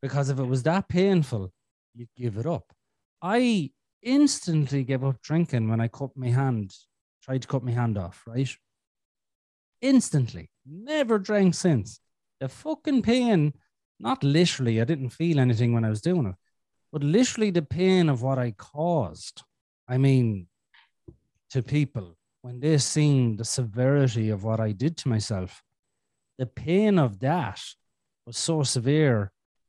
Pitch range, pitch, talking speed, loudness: 115-165 Hz, 135 Hz, 150 wpm, -25 LUFS